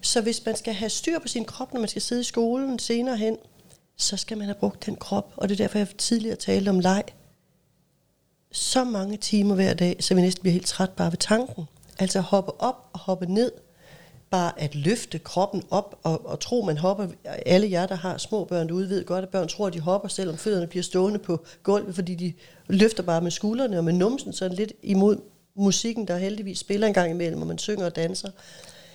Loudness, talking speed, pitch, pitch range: -25 LUFS, 230 wpm, 195 Hz, 180-215 Hz